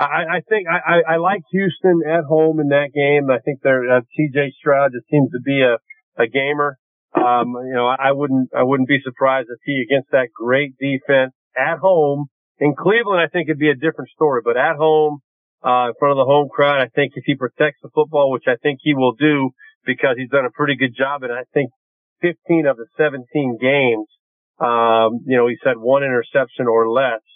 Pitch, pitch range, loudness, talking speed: 140 Hz, 130-155 Hz, -17 LUFS, 215 wpm